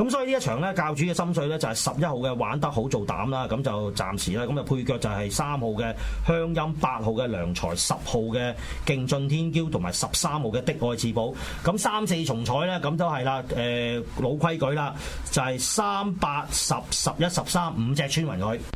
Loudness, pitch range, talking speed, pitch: -26 LUFS, 120-165 Hz, 295 characters per minute, 140 Hz